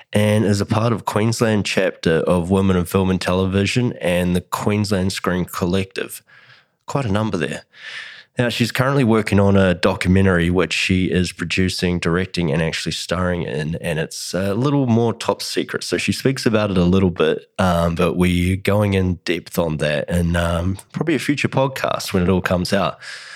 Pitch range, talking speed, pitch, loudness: 90-105 Hz, 185 wpm, 95 Hz, -19 LUFS